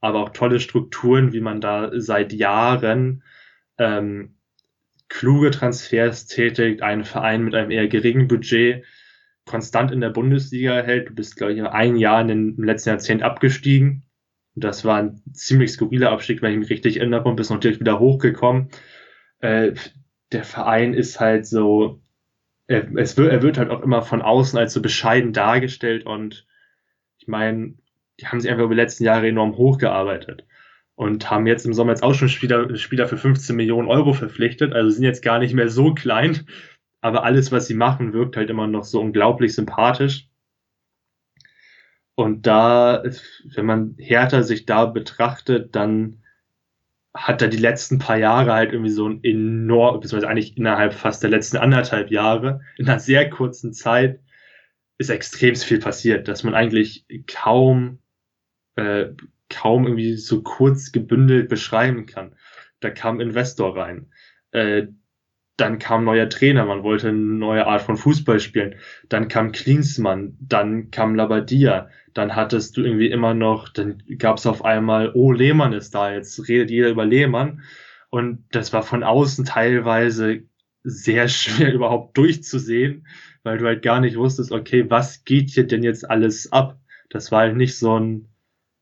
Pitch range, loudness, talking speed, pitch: 110-130 Hz, -19 LUFS, 165 wpm, 115 Hz